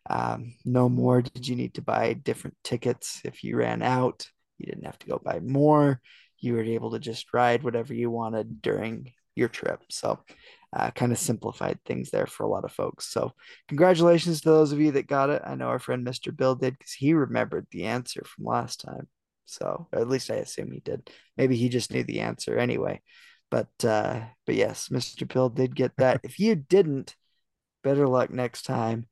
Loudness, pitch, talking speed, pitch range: -27 LUFS, 125 Hz, 205 wpm, 120-140 Hz